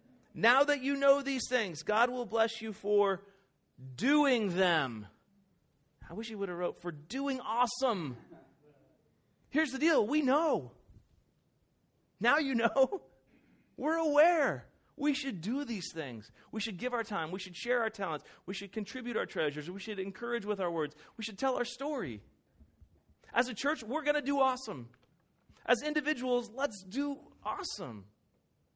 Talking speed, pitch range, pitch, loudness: 160 wpm, 185-270 Hz, 230 Hz, -33 LUFS